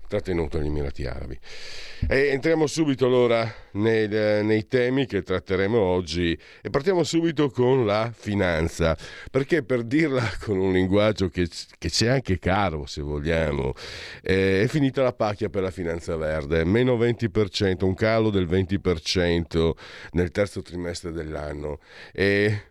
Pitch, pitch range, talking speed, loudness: 95 Hz, 85-115 Hz, 140 wpm, -24 LUFS